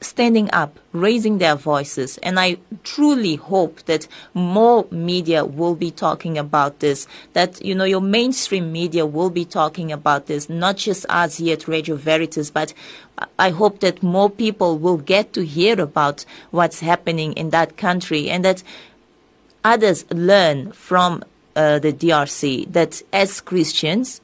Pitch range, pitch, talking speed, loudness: 155-190 Hz, 175 Hz, 160 wpm, -18 LUFS